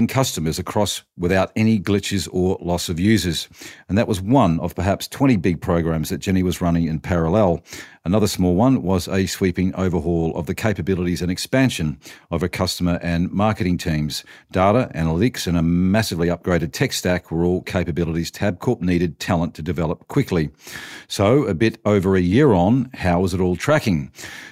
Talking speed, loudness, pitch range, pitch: 175 wpm, -20 LUFS, 85-100 Hz, 90 Hz